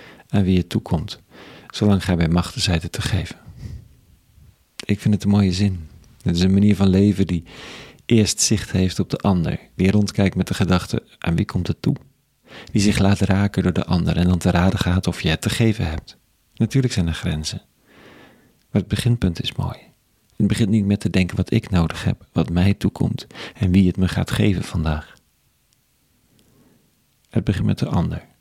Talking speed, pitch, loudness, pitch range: 195 wpm, 95 Hz, -20 LUFS, 90-105 Hz